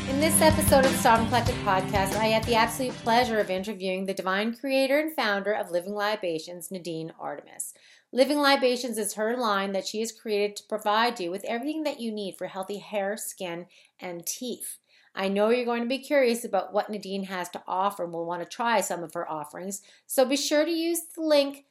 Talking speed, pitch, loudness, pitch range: 215 wpm, 210 Hz, -26 LUFS, 190-250 Hz